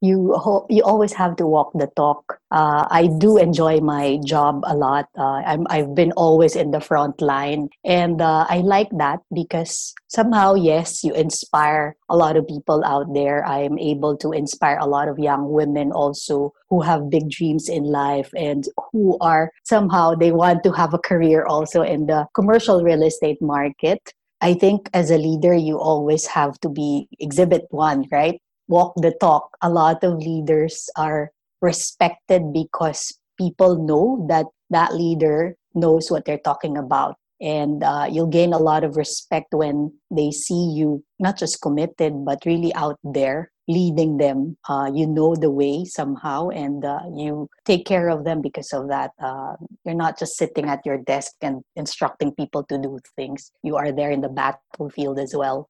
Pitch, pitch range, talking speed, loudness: 155 Hz, 145-170 Hz, 180 wpm, -19 LUFS